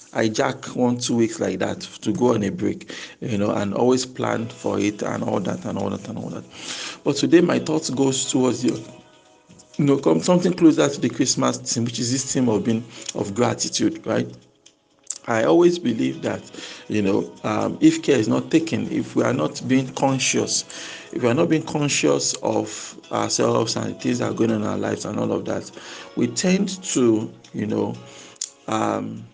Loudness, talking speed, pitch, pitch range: -22 LUFS, 200 wpm, 125 Hz, 110-155 Hz